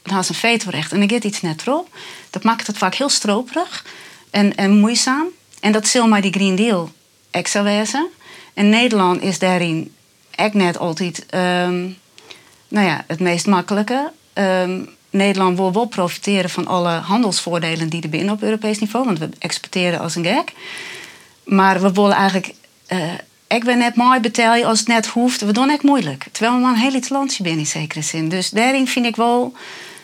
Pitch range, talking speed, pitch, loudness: 180-235 Hz, 190 wpm, 205 Hz, -17 LUFS